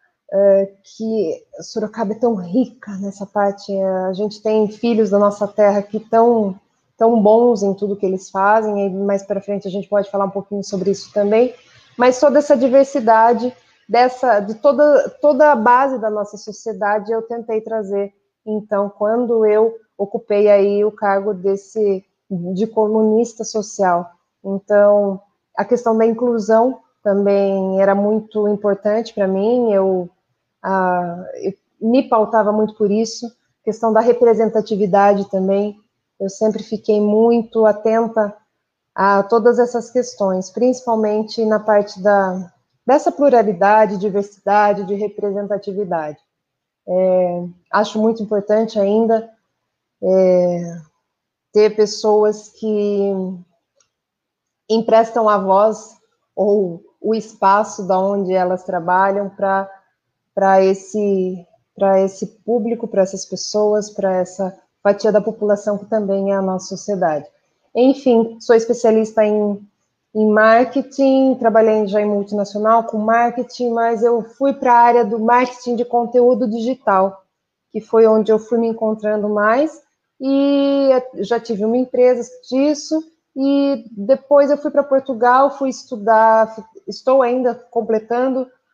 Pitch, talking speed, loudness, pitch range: 215 Hz, 130 wpm, -16 LUFS, 200-230 Hz